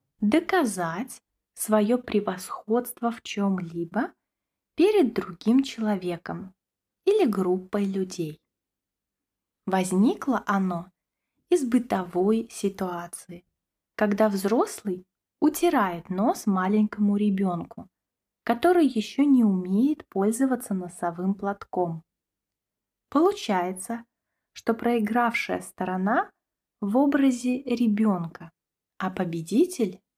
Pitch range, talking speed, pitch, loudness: 185-240 Hz, 75 wpm, 210 Hz, -25 LUFS